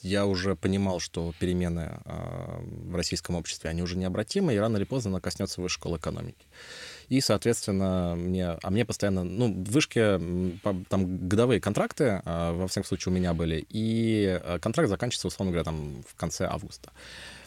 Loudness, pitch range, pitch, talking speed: -29 LUFS, 90-105 Hz, 95 Hz, 160 wpm